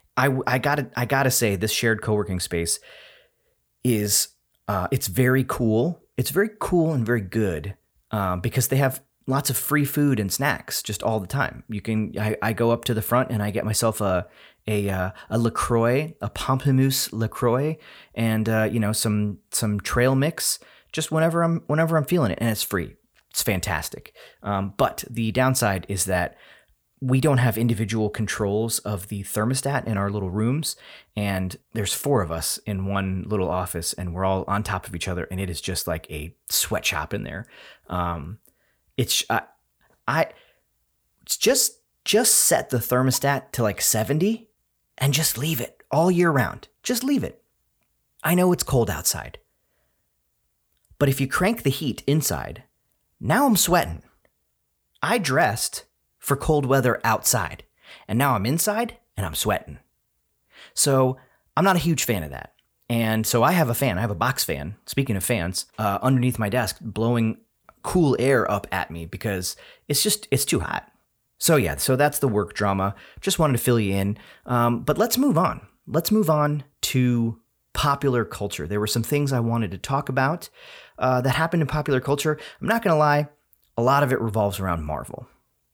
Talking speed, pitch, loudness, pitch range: 180 wpm, 120 Hz, -23 LUFS, 100-140 Hz